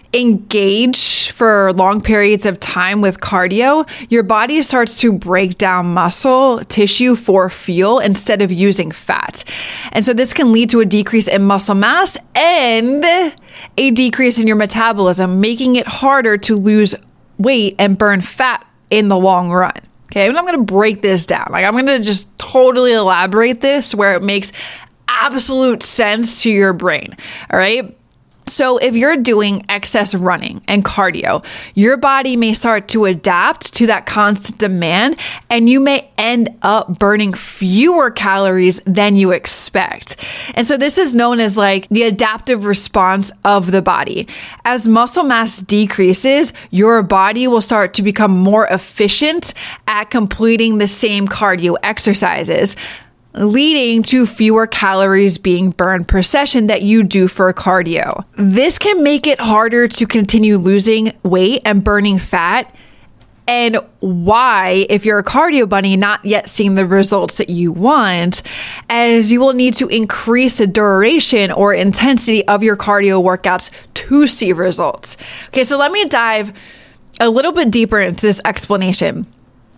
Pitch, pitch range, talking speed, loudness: 215 Hz, 195-240 Hz, 155 wpm, -12 LUFS